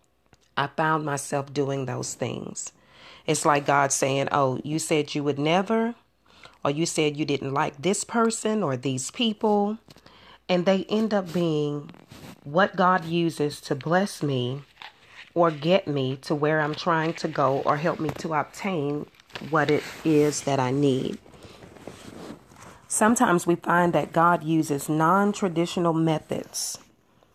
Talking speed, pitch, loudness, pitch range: 145 wpm, 155 Hz, -25 LUFS, 145-180 Hz